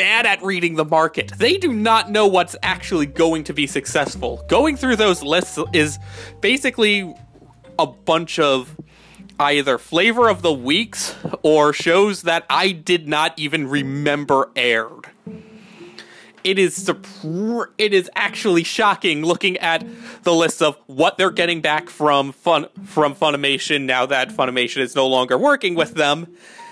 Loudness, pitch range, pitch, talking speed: -18 LUFS, 145-195 Hz, 165 Hz, 150 wpm